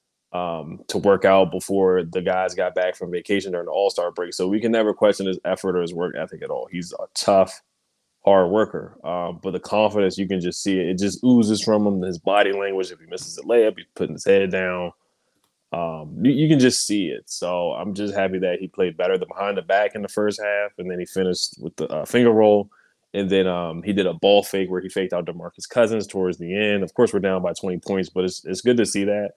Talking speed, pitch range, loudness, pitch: 250 wpm, 90-105 Hz, -21 LUFS, 95 Hz